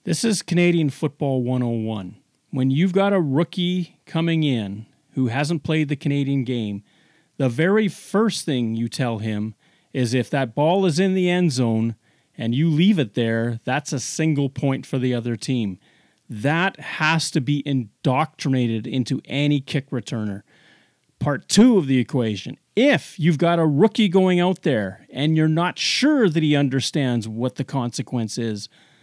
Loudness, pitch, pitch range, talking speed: -21 LUFS, 140 Hz, 120-165 Hz, 165 wpm